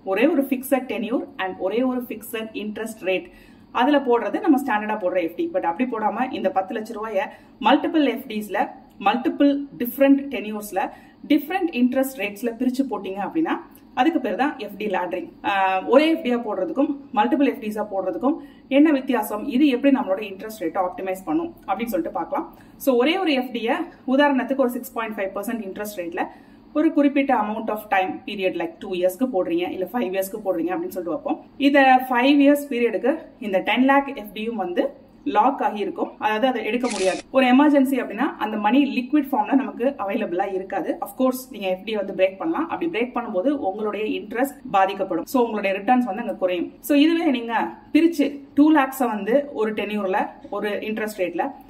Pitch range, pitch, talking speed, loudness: 210-280 Hz, 255 Hz, 145 wpm, -22 LUFS